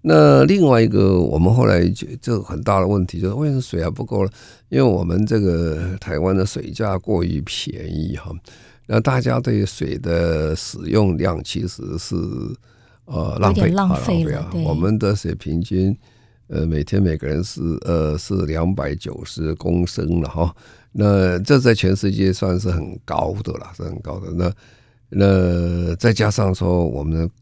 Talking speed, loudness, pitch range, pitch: 230 characters per minute, -19 LUFS, 85-110 Hz, 95 Hz